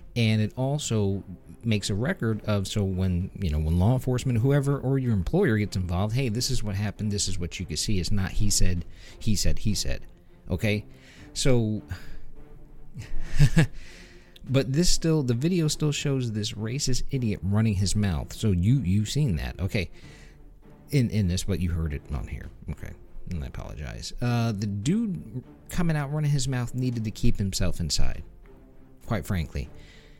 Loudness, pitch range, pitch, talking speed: -27 LUFS, 90-125 Hz, 105 Hz, 175 wpm